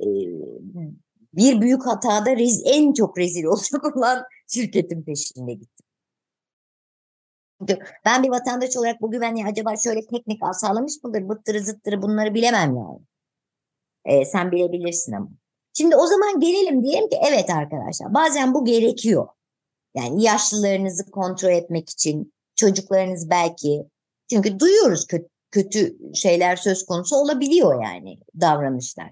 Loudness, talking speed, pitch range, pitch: -20 LUFS, 120 wpm, 175-250 Hz, 210 Hz